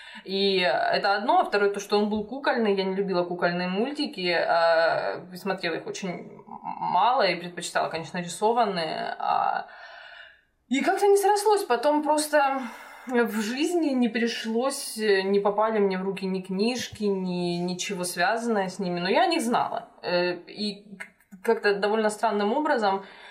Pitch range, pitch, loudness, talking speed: 190-270 Hz, 210 Hz, -25 LUFS, 140 wpm